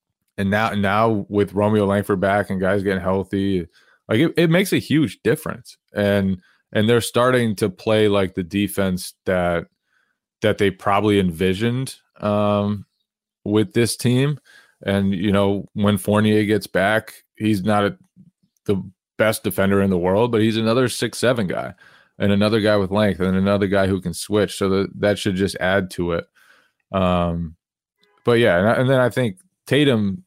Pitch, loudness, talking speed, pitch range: 100 Hz, -20 LUFS, 170 wpm, 95-110 Hz